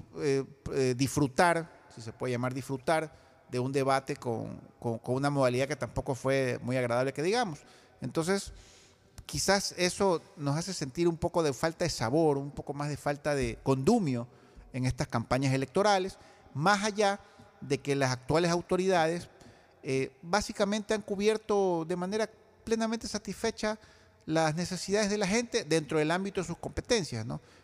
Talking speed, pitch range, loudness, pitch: 160 wpm, 135-195 Hz, -30 LUFS, 155 Hz